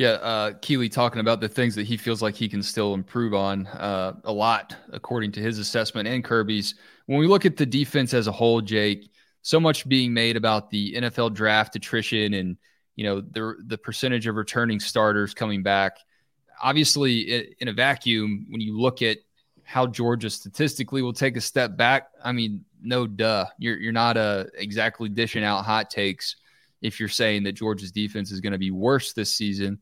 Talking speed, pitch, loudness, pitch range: 195 wpm, 110 Hz, -24 LUFS, 105-120 Hz